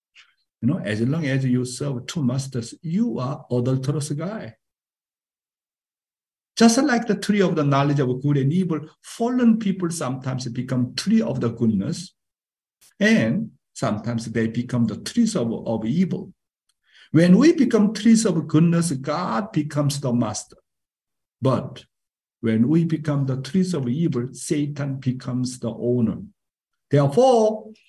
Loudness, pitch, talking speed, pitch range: -22 LUFS, 150 Hz, 140 wpm, 125-190 Hz